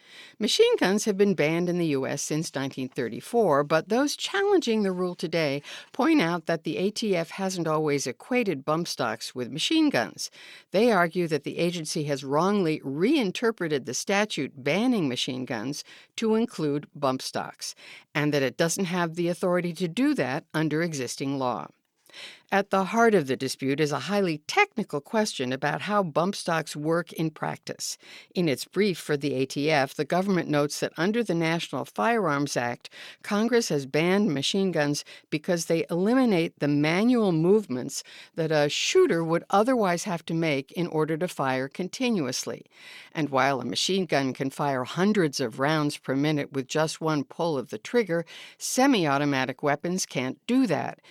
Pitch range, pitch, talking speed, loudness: 145-200 Hz, 165 Hz, 165 wpm, -26 LUFS